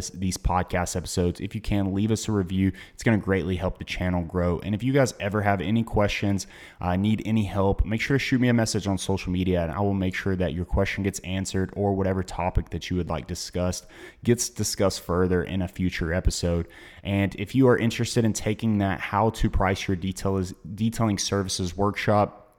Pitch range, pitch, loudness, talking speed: 90-105 Hz, 95 Hz, -26 LUFS, 215 wpm